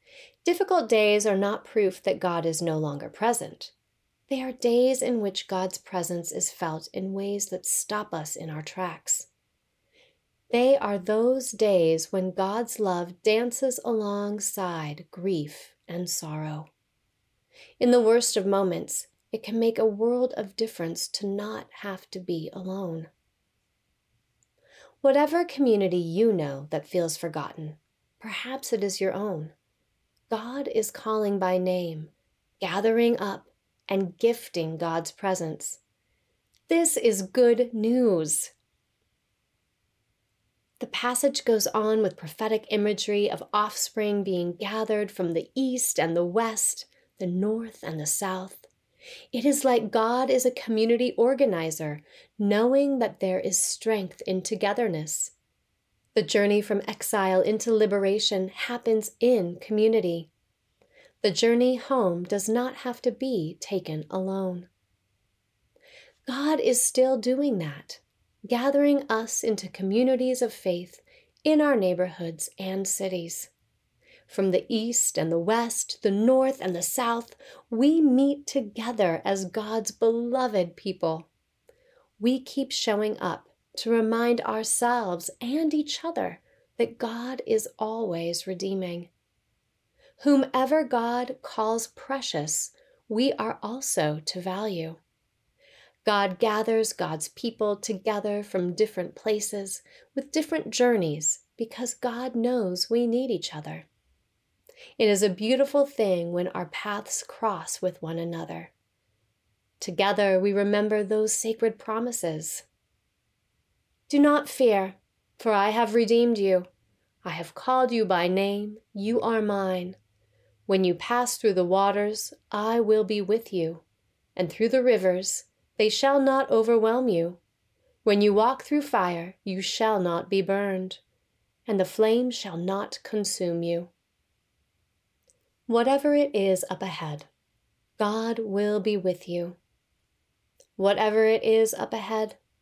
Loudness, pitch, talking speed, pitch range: -26 LUFS, 210 Hz, 130 wpm, 180-240 Hz